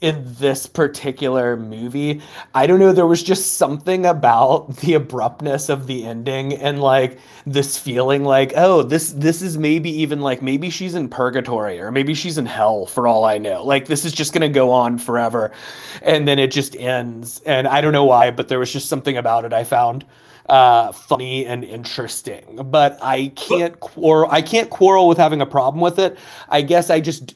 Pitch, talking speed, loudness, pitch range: 140 Hz, 200 wpm, -17 LUFS, 130-160 Hz